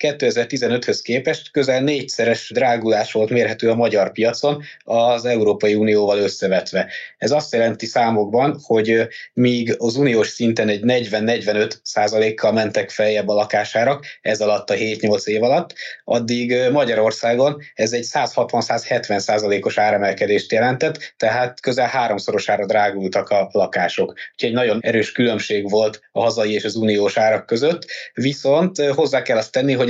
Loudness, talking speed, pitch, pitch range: -18 LUFS, 140 wpm, 115 Hz, 105-125 Hz